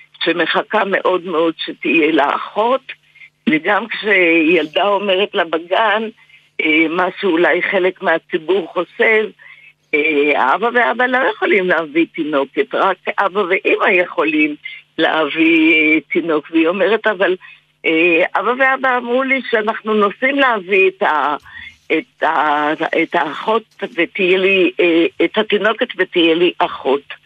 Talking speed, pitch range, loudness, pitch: 110 wpm, 170-245 Hz, -15 LUFS, 195 Hz